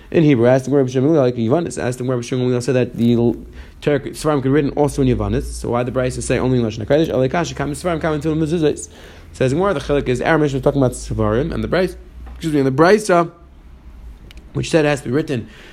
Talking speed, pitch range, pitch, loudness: 185 wpm, 120-150 Hz, 130 Hz, -18 LUFS